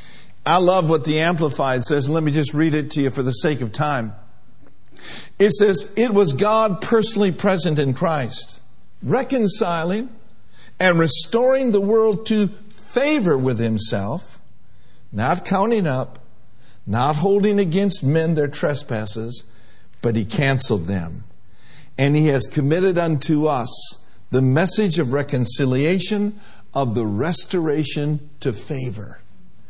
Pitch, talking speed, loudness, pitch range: 150 Hz, 130 wpm, -19 LUFS, 125-190 Hz